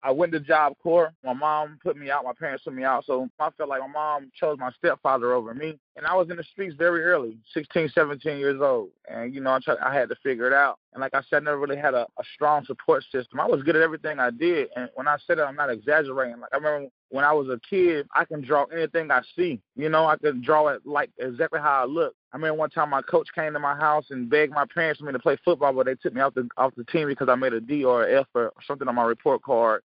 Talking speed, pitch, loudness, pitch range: 290 wpm, 150 Hz, -24 LUFS, 130-160 Hz